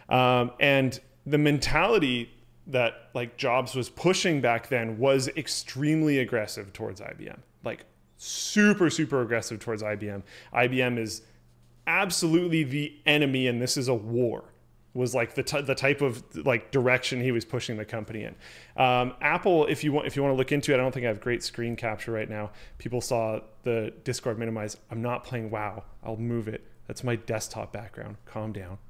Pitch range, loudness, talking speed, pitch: 110-140 Hz, -27 LUFS, 185 wpm, 125 Hz